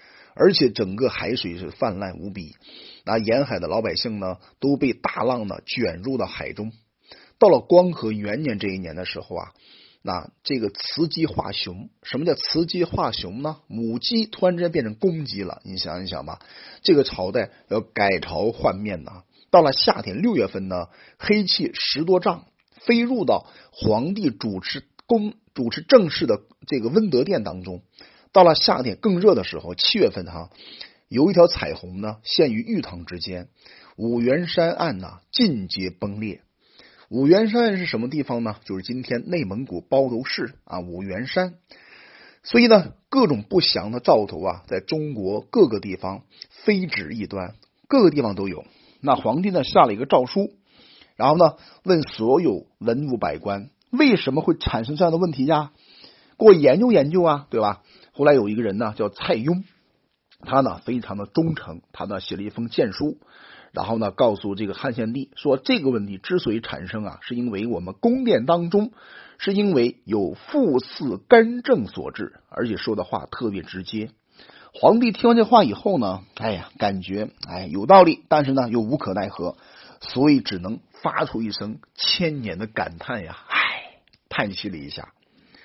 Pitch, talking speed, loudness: 125 Hz, 255 characters per minute, -21 LUFS